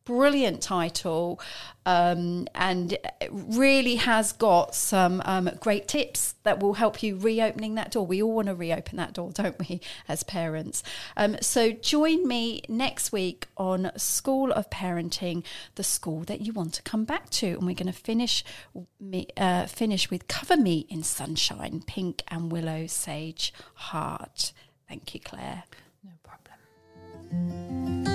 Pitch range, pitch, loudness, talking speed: 170-220 Hz, 185 Hz, -27 LUFS, 150 wpm